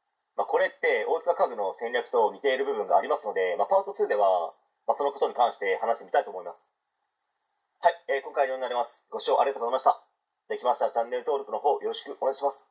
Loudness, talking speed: -27 LUFS, 470 characters per minute